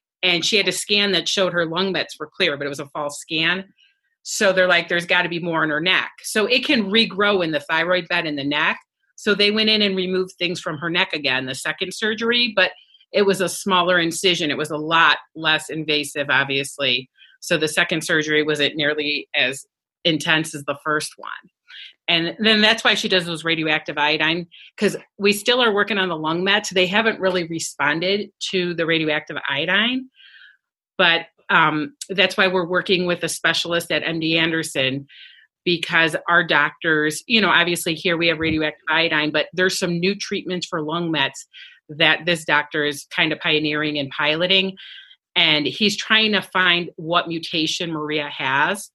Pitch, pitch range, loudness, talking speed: 175 Hz, 155-190 Hz, -19 LUFS, 190 wpm